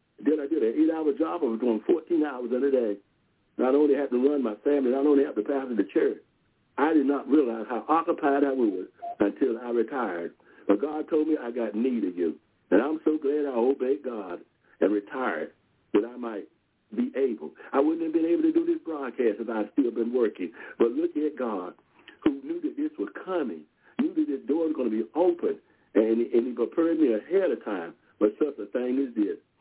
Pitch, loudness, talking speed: 145 Hz, -27 LUFS, 225 wpm